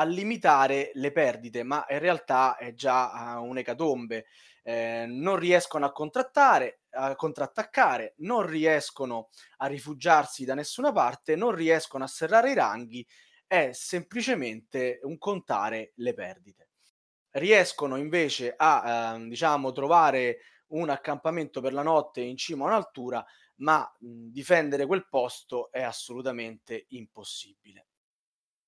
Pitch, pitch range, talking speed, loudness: 140 Hz, 125-170 Hz, 125 wpm, -27 LUFS